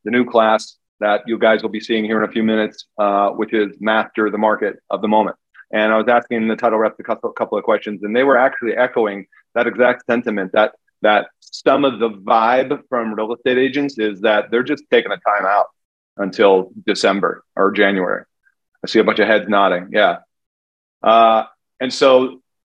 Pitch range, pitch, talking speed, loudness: 105-120 Hz, 110 Hz, 205 wpm, -17 LUFS